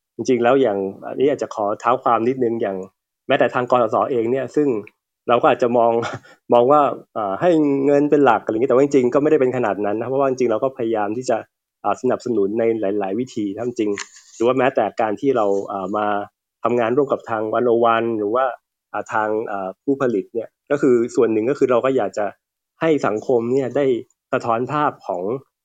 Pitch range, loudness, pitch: 105-135 Hz, -19 LUFS, 115 Hz